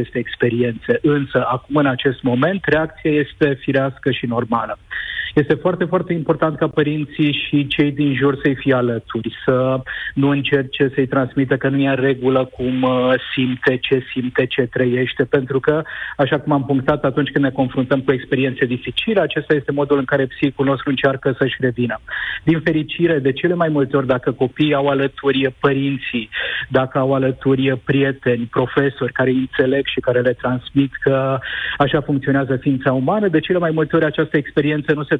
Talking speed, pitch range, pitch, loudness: 175 wpm, 130-150 Hz, 140 Hz, -18 LUFS